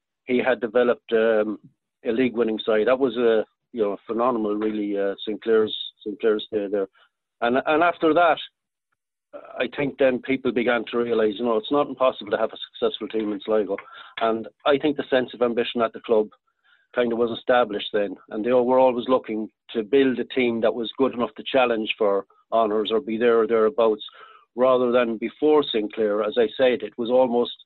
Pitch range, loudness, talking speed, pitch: 110-130 Hz, -23 LUFS, 195 wpm, 120 Hz